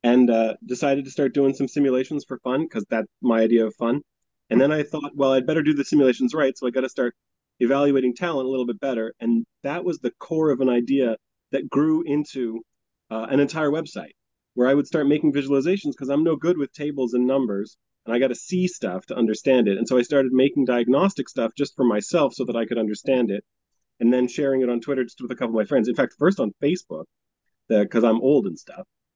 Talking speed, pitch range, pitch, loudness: 235 wpm, 120-145 Hz, 130 Hz, -22 LUFS